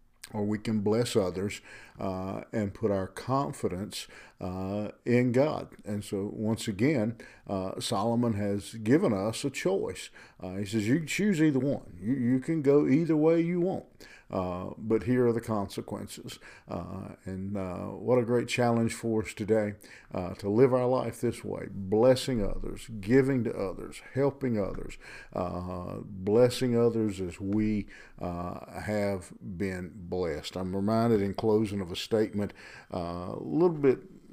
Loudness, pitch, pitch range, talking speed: -30 LUFS, 105 Hz, 95-125 Hz, 155 wpm